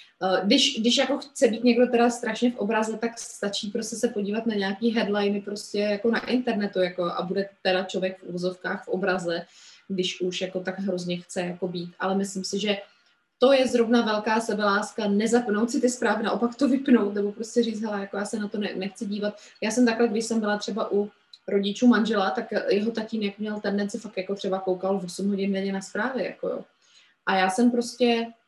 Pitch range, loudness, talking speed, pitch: 195-235 Hz, -25 LUFS, 205 wpm, 210 Hz